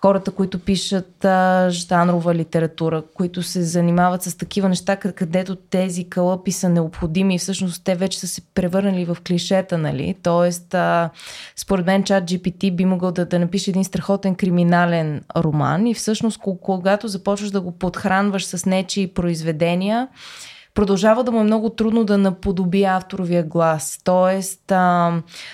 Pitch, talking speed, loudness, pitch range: 185 Hz, 150 wpm, -19 LUFS, 175-195 Hz